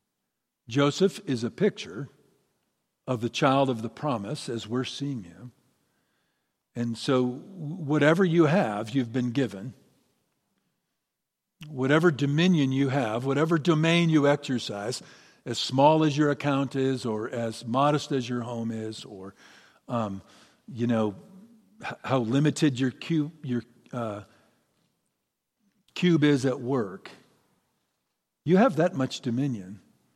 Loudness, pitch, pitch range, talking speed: -26 LUFS, 135 Hz, 120-155 Hz, 125 wpm